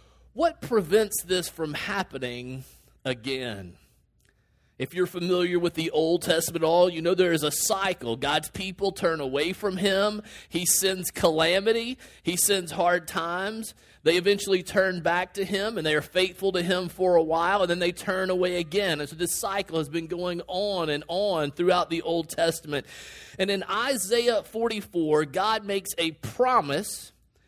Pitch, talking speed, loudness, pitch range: 180 Hz, 170 wpm, -26 LUFS, 165-195 Hz